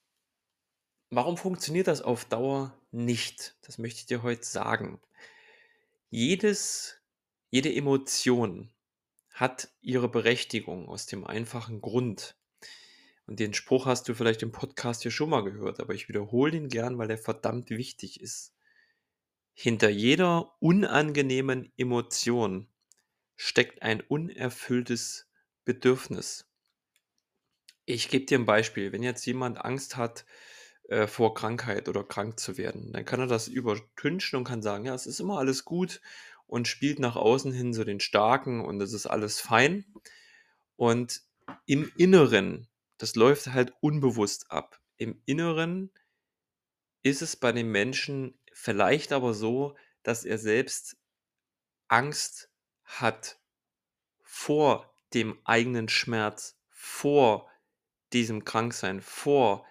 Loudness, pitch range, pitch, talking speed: -28 LUFS, 115-145 Hz, 125 Hz, 125 wpm